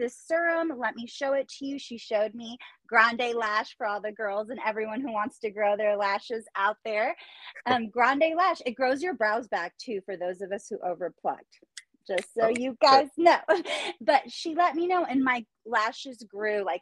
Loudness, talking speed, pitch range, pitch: -27 LUFS, 205 wpm, 210-275 Hz, 235 Hz